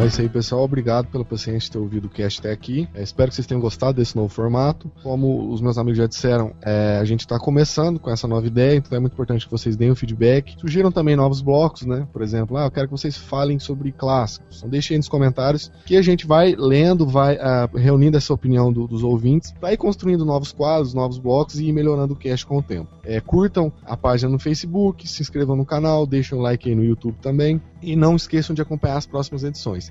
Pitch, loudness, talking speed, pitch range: 135 Hz, -20 LUFS, 245 wpm, 120-150 Hz